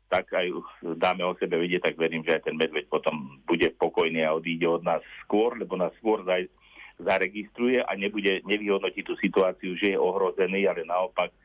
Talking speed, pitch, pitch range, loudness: 180 wpm, 95 Hz, 85-105 Hz, -27 LUFS